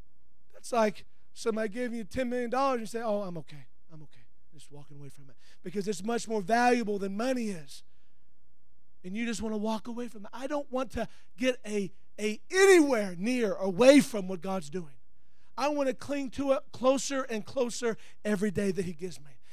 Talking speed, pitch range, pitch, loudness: 205 wpm, 190-250 Hz, 220 Hz, -29 LUFS